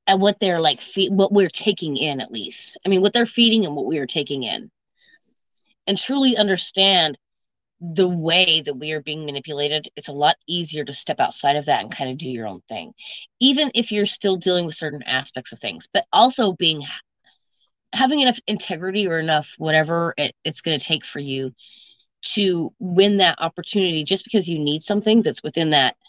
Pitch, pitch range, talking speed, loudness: 175 Hz, 150-205 Hz, 200 wpm, -20 LUFS